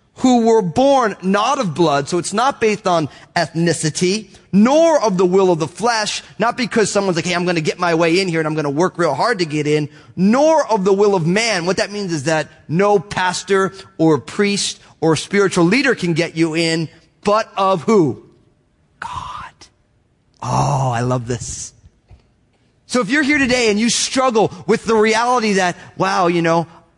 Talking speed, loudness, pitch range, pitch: 190 wpm, -16 LUFS, 165-220 Hz, 185 Hz